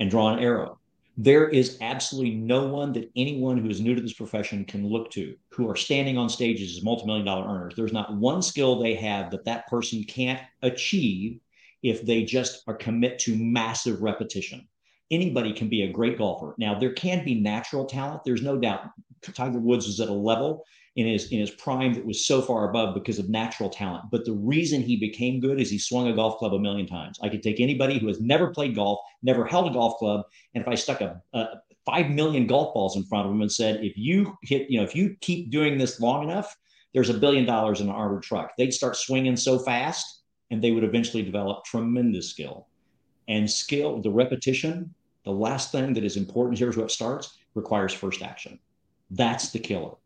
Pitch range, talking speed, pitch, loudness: 110-130 Hz, 215 wpm, 120 Hz, -26 LUFS